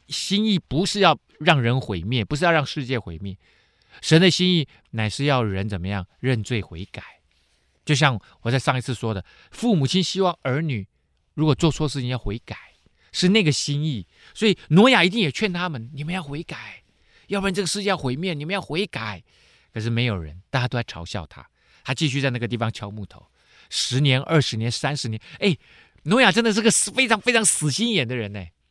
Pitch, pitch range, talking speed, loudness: 135 Hz, 110-180 Hz, 295 characters per minute, -22 LUFS